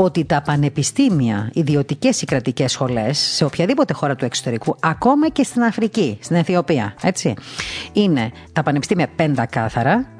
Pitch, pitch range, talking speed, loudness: 150 Hz, 130-175 Hz, 140 wpm, -18 LUFS